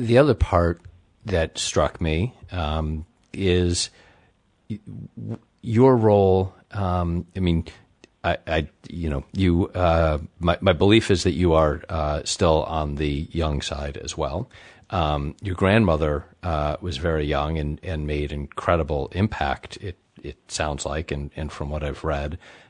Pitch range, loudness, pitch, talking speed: 75-95 Hz, -23 LUFS, 85 Hz, 150 wpm